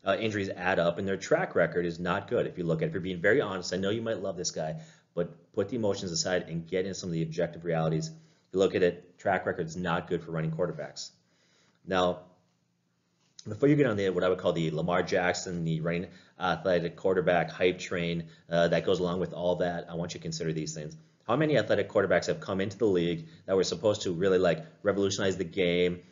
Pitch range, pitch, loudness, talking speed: 85-95 Hz, 90 Hz, -29 LUFS, 240 wpm